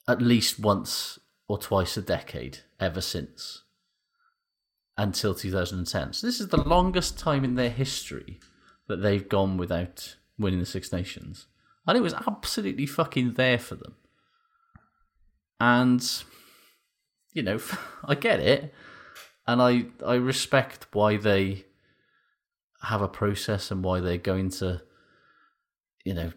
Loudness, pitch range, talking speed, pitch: -27 LUFS, 95-160 Hz, 130 wpm, 120 Hz